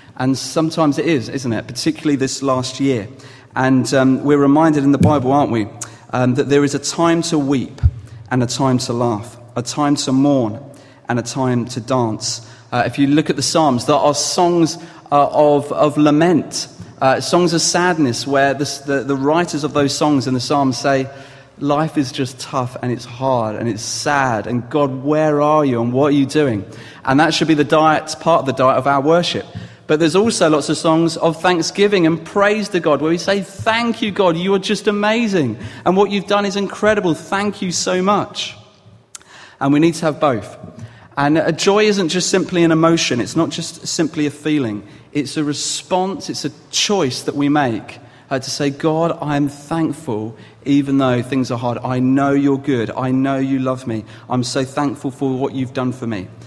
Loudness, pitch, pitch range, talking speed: -17 LUFS, 140 Hz, 130-160 Hz, 205 wpm